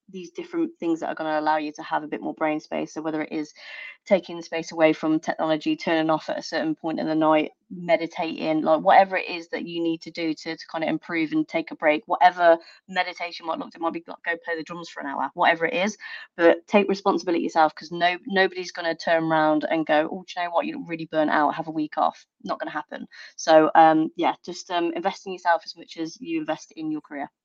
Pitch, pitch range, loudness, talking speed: 165 Hz, 155-185 Hz, -24 LUFS, 260 wpm